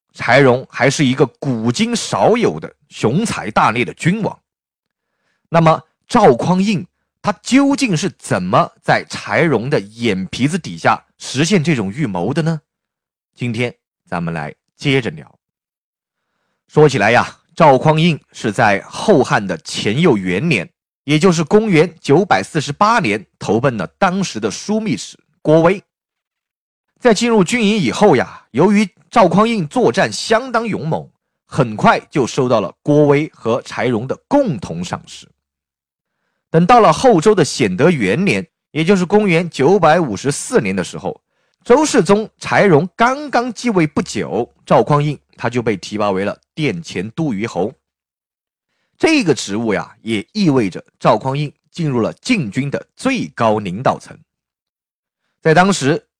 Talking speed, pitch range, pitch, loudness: 205 characters per minute, 140-210 Hz, 165 Hz, -15 LUFS